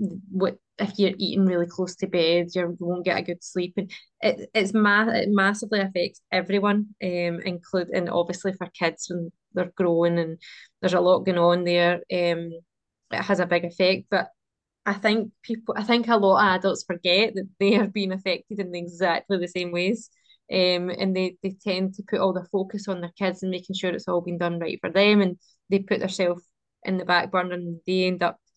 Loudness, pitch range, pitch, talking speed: -24 LUFS, 175-200 Hz, 185 Hz, 210 wpm